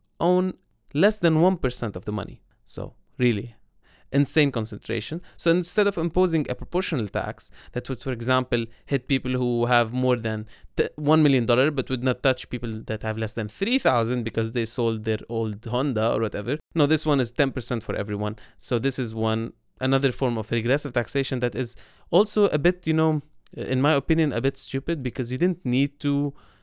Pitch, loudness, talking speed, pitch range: 130 Hz, -24 LUFS, 195 wpm, 115-145 Hz